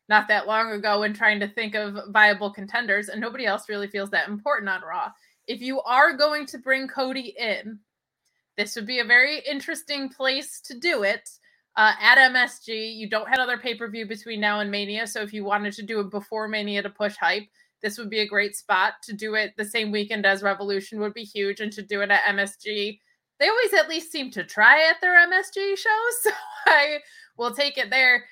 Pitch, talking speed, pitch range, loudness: 220 Hz, 220 wpm, 205-265 Hz, -22 LUFS